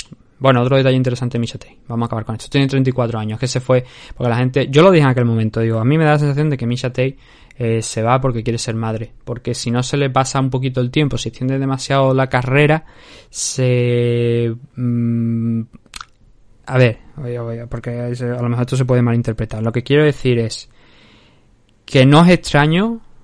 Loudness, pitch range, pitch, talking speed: -16 LUFS, 115-135 Hz, 125 Hz, 210 wpm